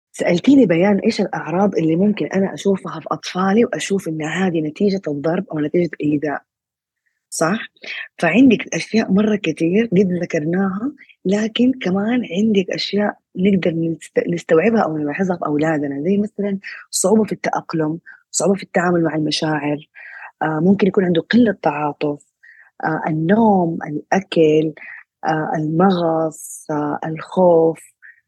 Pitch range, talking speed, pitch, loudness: 155-200 Hz, 125 wpm, 175 Hz, -18 LUFS